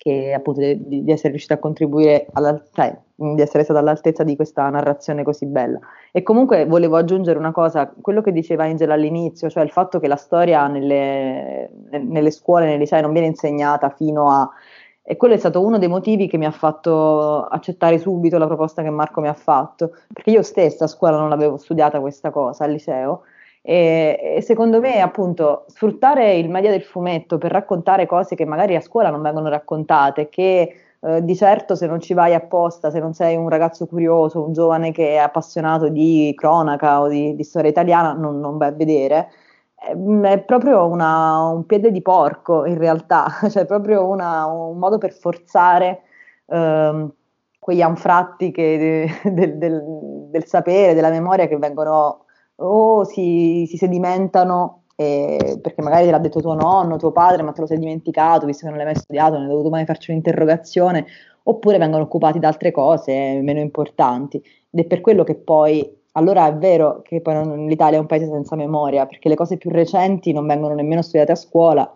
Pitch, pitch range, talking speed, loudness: 160 Hz, 150-175 Hz, 190 wpm, -17 LUFS